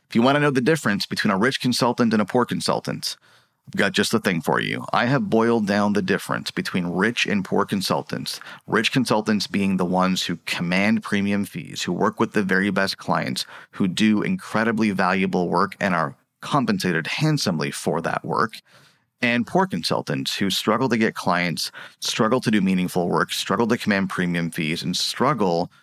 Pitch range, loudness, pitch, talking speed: 95-120 Hz, -22 LUFS, 105 Hz, 190 wpm